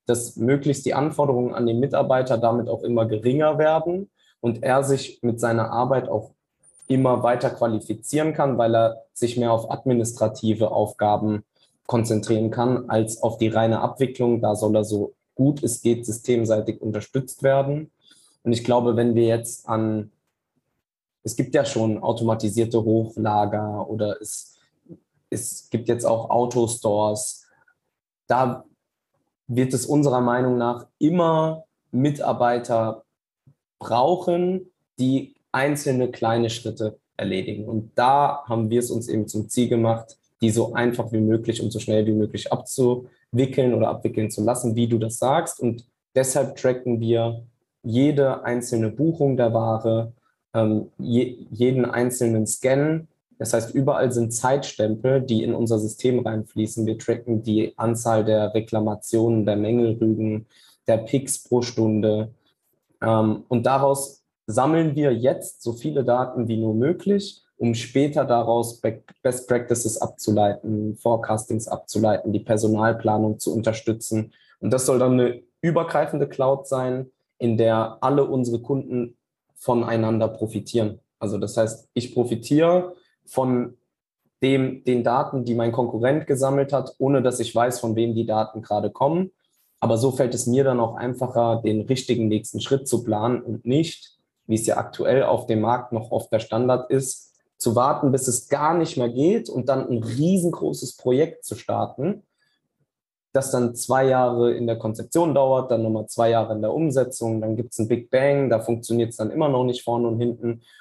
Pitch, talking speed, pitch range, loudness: 120 Hz, 150 wpm, 110-130 Hz, -22 LUFS